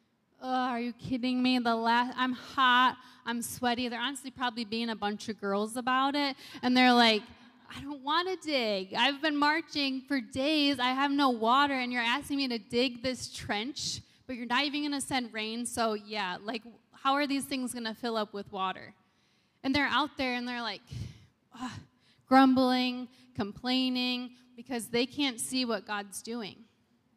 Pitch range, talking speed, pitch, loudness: 230-265 Hz, 185 wpm, 250 Hz, -30 LUFS